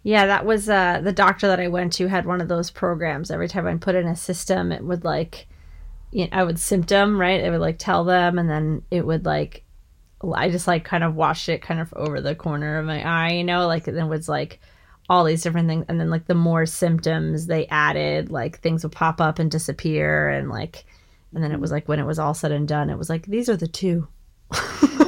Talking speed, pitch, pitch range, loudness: 245 wpm, 165 Hz, 155-180 Hz, -22 LUFS